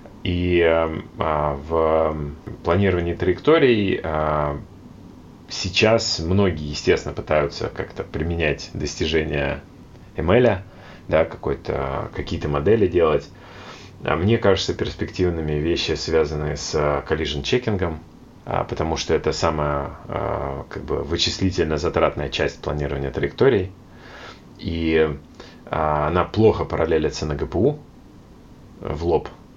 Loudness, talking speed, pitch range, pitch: -22 LUFS, 90 wpm, 75-95 Hz, 80 Hz